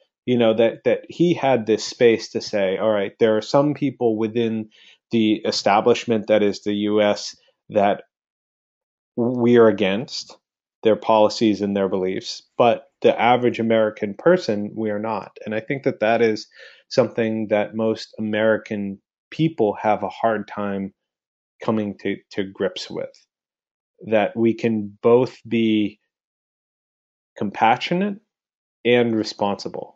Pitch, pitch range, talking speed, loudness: 110 Hz, 105-120 Hz, 135 wpm, -21 LUFS